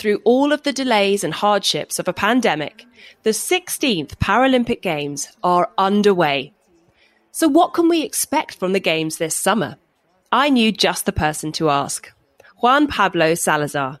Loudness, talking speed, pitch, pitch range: -18 LUFS, 155 wpm, 200 Hz, 165-245 Hz